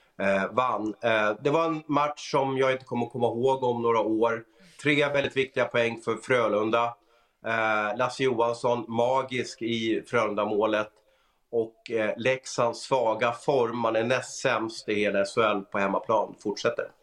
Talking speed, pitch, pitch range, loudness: 130 wpm, 115 Hz, 110-130 Hz, -27 LUFS